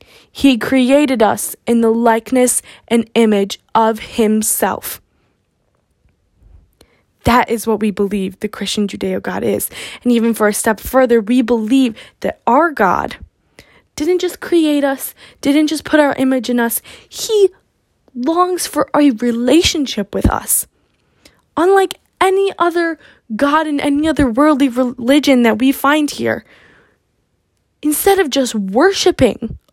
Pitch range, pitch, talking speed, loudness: 230-305 Hz, 260 Hz, 135 wpm, -15 LUFS